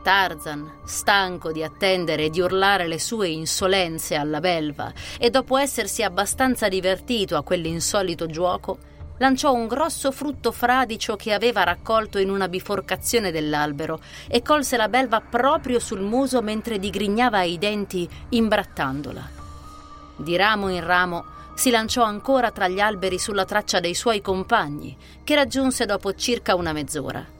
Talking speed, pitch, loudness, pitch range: 140 wpm, 195 Hz, -22 LUFS, 170-230 Hz